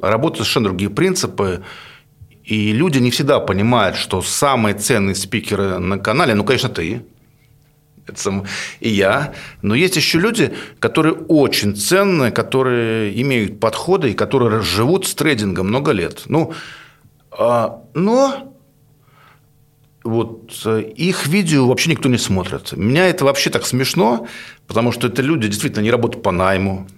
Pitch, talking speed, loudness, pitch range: 125 Hz, 140 wpm, -17 LUFS, 105-145 Hz